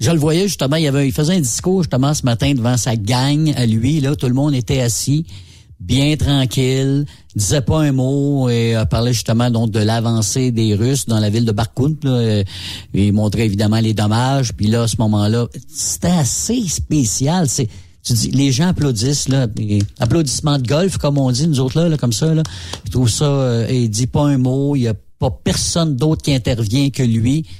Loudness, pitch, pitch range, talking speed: -16 LUFS, 130 Hz, 115-145 Hz, 205 wpm